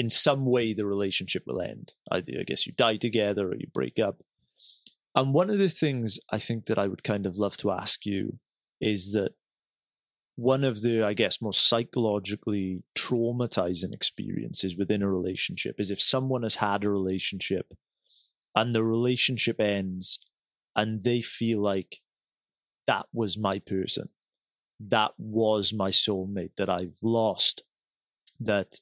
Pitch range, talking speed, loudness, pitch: 100-115 Hz, 155 wpm, -26 LUFS, 110 Hz